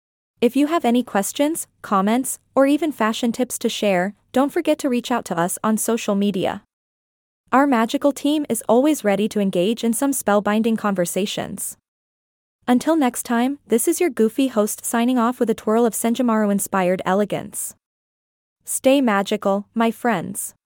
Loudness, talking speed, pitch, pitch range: -20 LUFS, 155 wpm, 230 Hz, 200-255 Hz